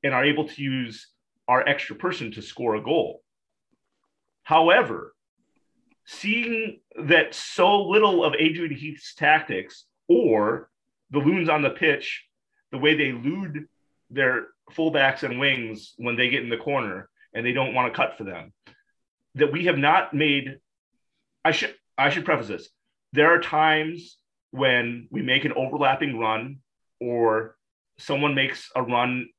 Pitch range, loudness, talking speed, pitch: 125-160 Hz, -23 LUFS, 150 wpm, 140 Hz